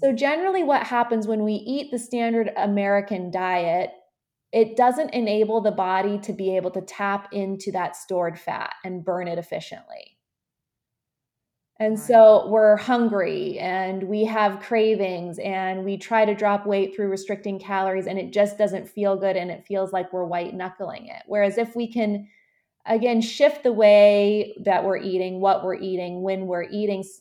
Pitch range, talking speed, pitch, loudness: 190-220 Hz, 170 wpm, 200 Hz, -22 LUFS